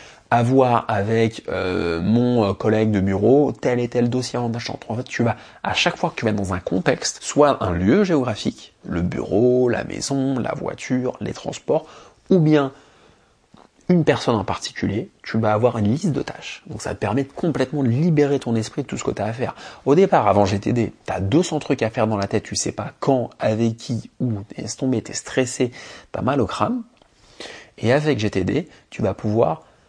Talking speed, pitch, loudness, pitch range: 205 wpm, 120 Hz, -21 LUFS, 110-140 Hz